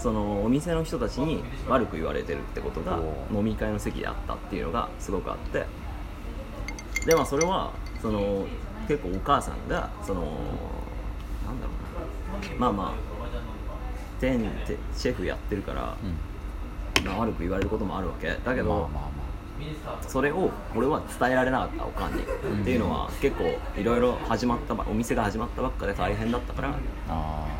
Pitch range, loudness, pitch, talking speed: 75-110 Hz, -29 LUFS, 95 Hz, 320 characters per minute